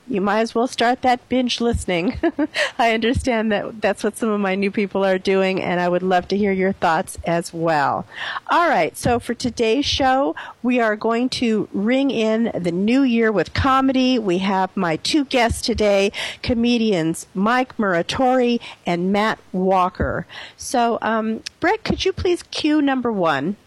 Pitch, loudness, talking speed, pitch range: 225 Hz, -19 LUFS, 170 wpm, 195-250 Hz